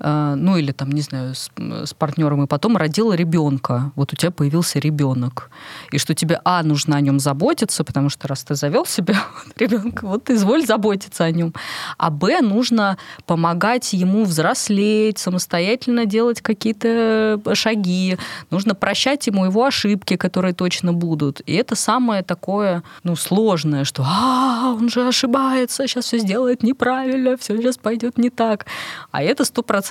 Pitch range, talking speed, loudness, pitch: 160-230 Hz, 160 wpm, -19 LUFS, 195 Hz